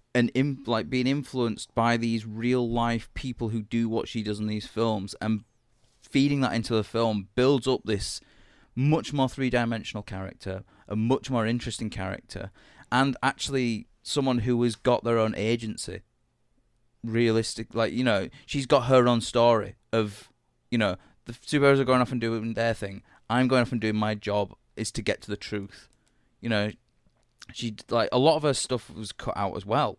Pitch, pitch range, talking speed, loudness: 115 Hz, 105-125 Hz, 190 wpm, -27 LUFS